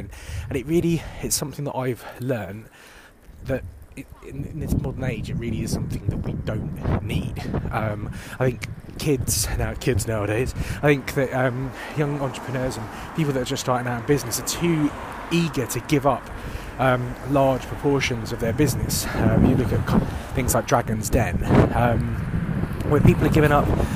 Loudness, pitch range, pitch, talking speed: -23 LUFS, 110-140 Hz, 125 Hz, 175 wpm